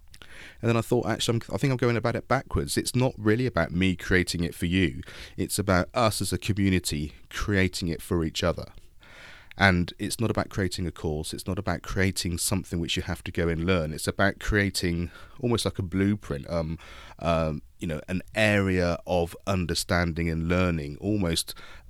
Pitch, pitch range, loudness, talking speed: 90 Hz, 85-100 Hz, -27 LUFS, 190 wpm